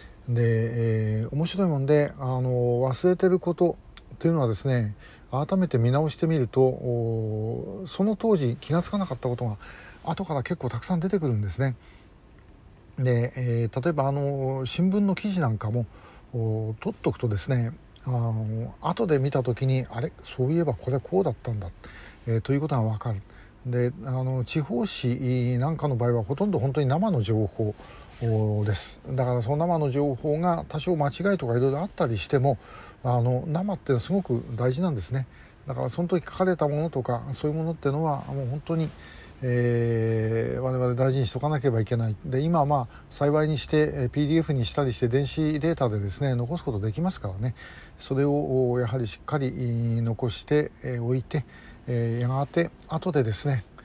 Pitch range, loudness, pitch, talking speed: 115-150 Hz, -26 LUFS, 130 Hz, 345 characters per minute